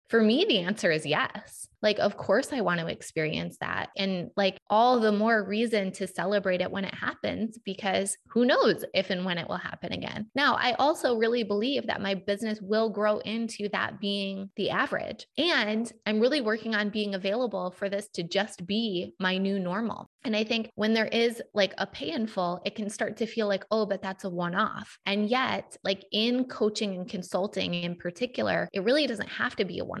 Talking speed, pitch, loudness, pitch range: 210 wpm, 210 Hz, -28 LUFS, 195-225 Hz